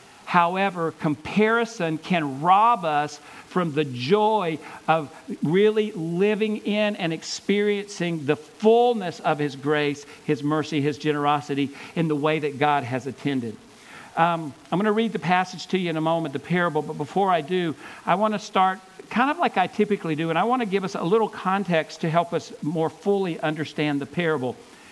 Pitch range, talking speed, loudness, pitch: 150-200 Hz, 180 wpm, -24 LUFS, 165 Hz